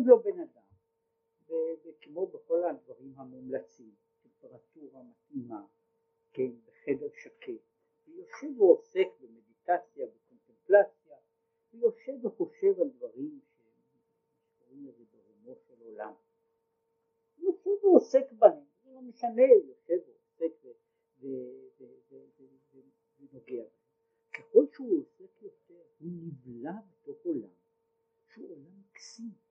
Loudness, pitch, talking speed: -29 LUFS, 335 Hz, 95 wpm